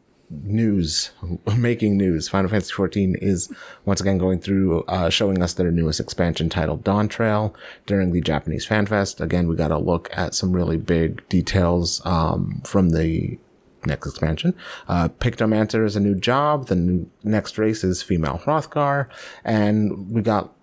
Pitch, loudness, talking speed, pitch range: 95 Hz, -22 LUFS, 165 wpm, 85-105 Hz